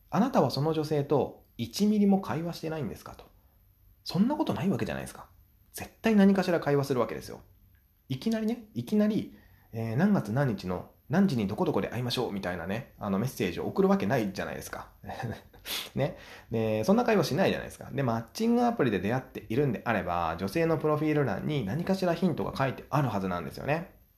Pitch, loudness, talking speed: 140 Hz, -29 LUFS, 445 characters per minute